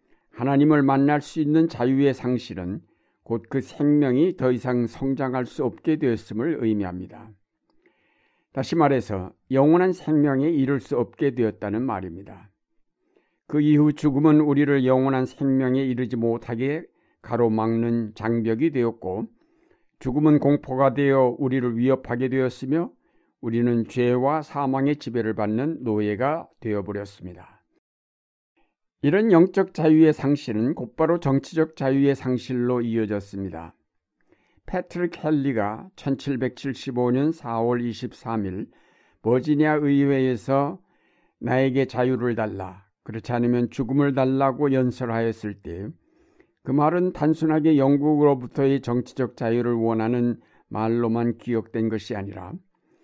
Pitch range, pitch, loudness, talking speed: 115-145 Hz, 130 Hz, -23 LUFS, 270 characters per minute